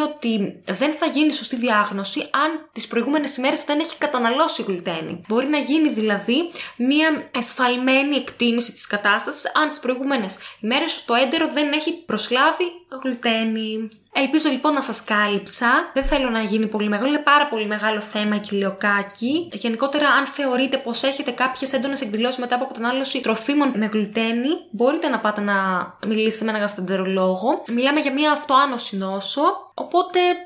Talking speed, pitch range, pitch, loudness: 160 wpm, 220-290 Hz, 250 Hz, -20 LUFS